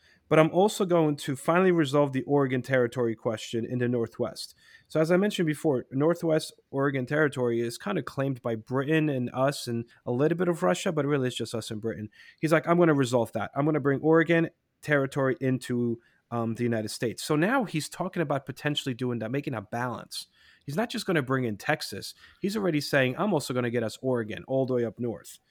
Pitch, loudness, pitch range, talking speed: 135 Hz, -27 LUFS, 120-155 Hz, 225 wpm